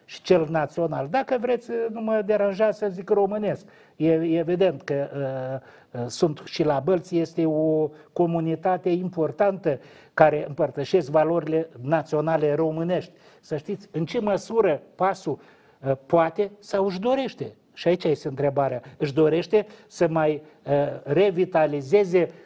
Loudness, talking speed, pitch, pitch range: -24 LUFS, 130 wpm, 170 Hz, 155-200 Hz